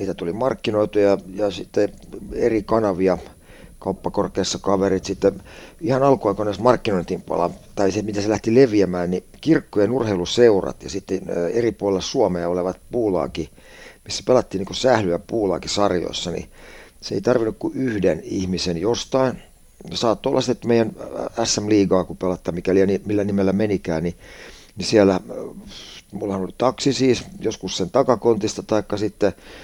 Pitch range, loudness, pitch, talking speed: 95-110 Hz, -21 LUFS, 100 Hz, 135 wpm